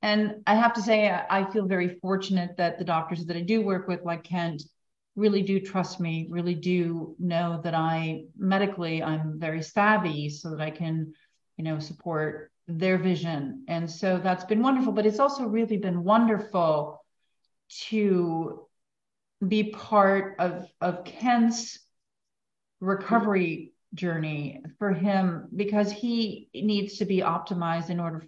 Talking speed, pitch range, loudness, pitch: 150 wpm, 165-210 Hz, -27 LUFS, 180 Hz